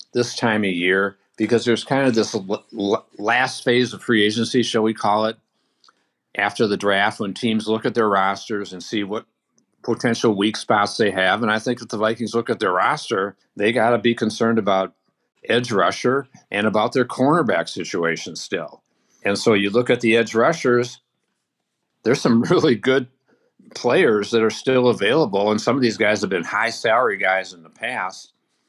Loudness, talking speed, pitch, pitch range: -20 LUFS, 185 wpm, 110 Hz, 105-120 Hz